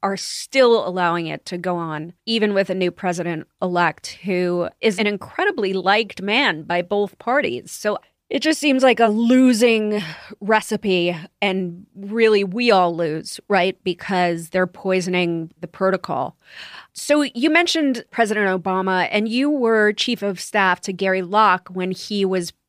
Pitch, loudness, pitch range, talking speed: 195 Hz, -19 LUFS, 180-220 Hz, 150 wpm